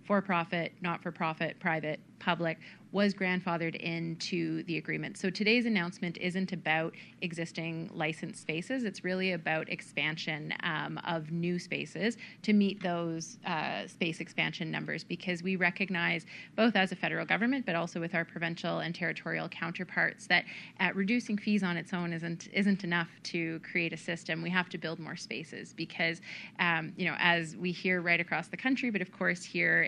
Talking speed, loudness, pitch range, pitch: 175 wpm, -32 LUFS, 165-190 Hz, 175 Hz